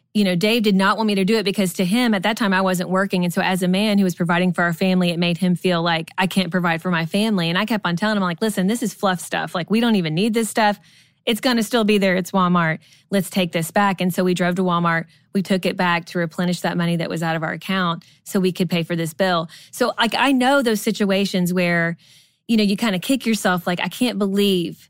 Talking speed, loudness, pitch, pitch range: 280 wpm, -20 LUFS, 185 Hz, 175-205 Hz